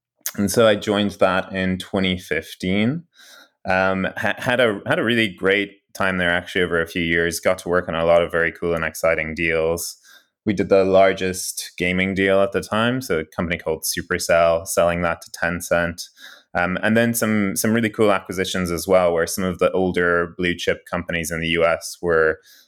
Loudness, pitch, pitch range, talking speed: -20 LUFS, 95 Hz, 85-100 Hz, 195 wpm